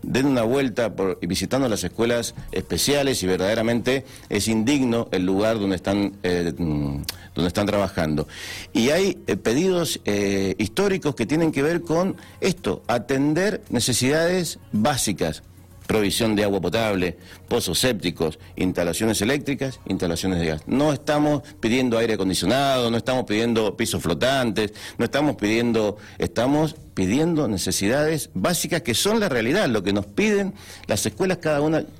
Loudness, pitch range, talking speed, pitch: -22 LUFS, 95-135 Hz, 140 wpm, 110 Hz